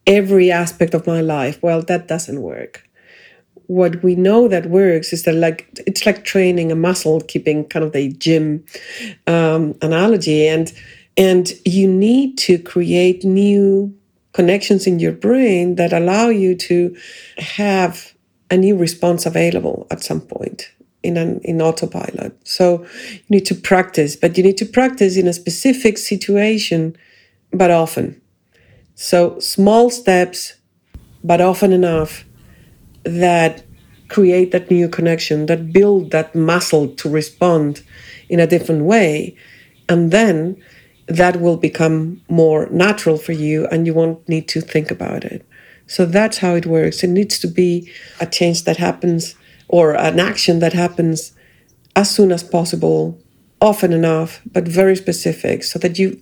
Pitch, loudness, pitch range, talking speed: 175 Hz, -15 LUFS, 160-190 Hz, 150 wpm